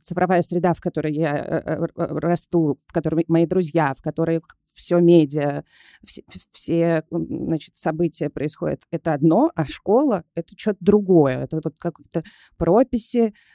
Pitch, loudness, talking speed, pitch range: 165 Hz, -21 LUFS, 135 wpm, 160-175 Hz